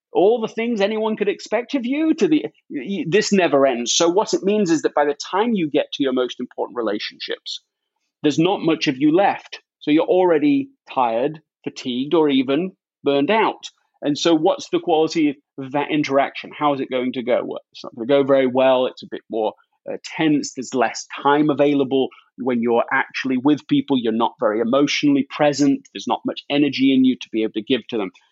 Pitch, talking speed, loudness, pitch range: 145 Hz, 210 wpm, -20 LUFS, 135-210 Hz